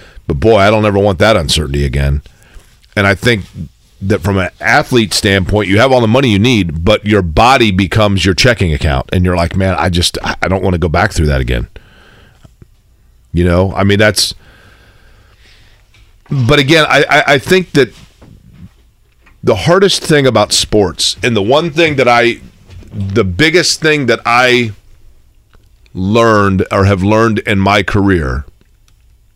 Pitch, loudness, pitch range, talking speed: 100 Hz, -11 LUFS, 95-115 Hz, 165 wpm